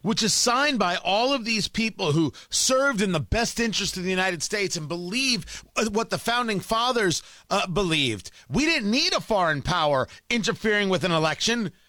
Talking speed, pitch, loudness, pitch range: 180 wpm, 210 Hz, -23 LUFS, 180-235 Hz